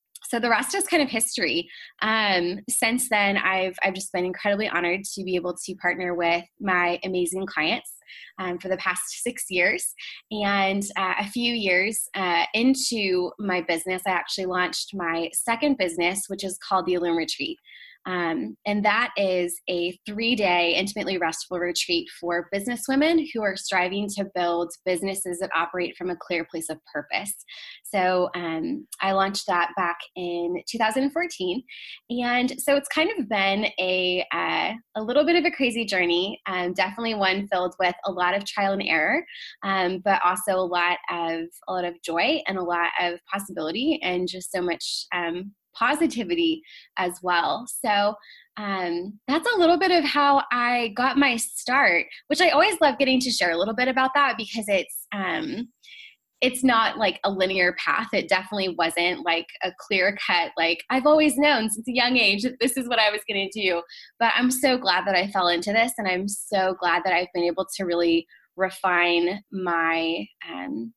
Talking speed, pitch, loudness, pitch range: 180 wpm, 195 Hz, -24 LUFS, 180-240 Hz